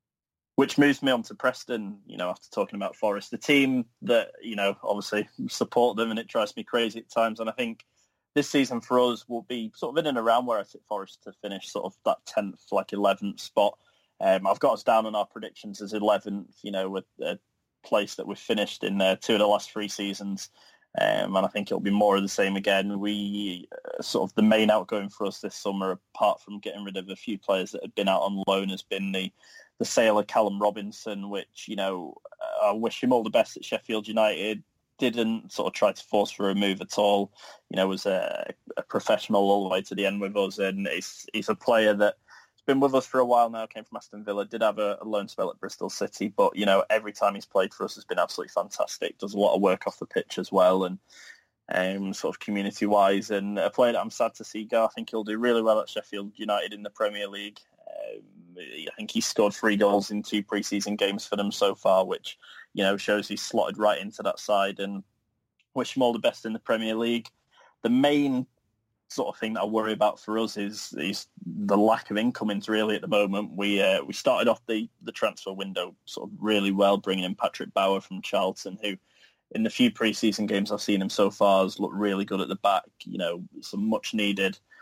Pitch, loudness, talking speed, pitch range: 105 Hz, -27 LUFS, 240 wpm, 100-115 Hz